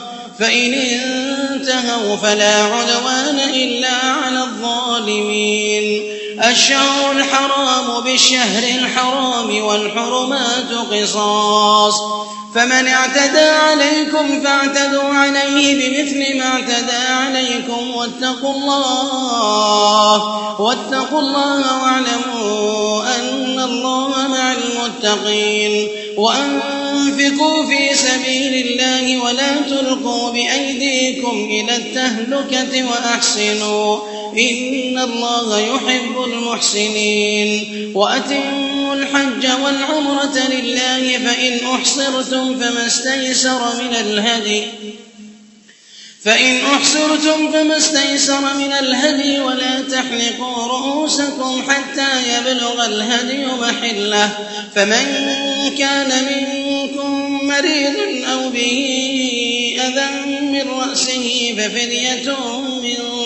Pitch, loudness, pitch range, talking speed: 255 Hz, -15 LUFS, 235-275 Hz, 75 wpm